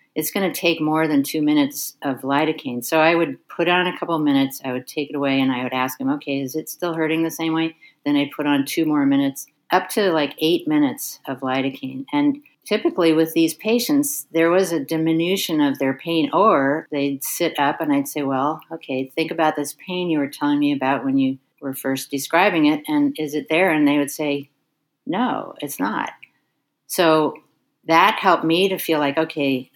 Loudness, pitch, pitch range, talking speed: -20 LUFS, 155 Hz, 140-170 Hz, 215 wpm